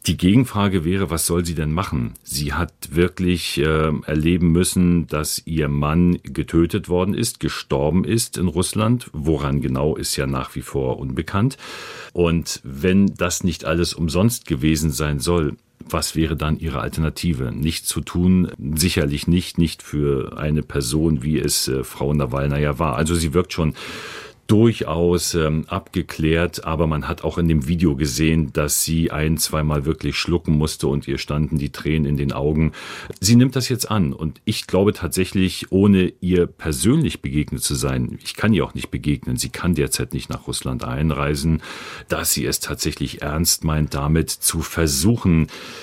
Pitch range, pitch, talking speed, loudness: 75-90 Hz, 80 Hz, 170 wpm, -20 LUFS